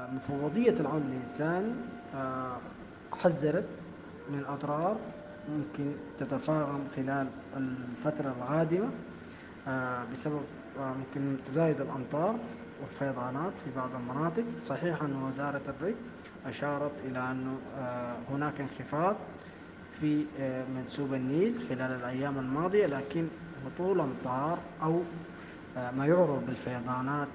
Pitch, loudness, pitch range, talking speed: 140 Hz, -34 LUFS, 130-155 Hz, 105 wpm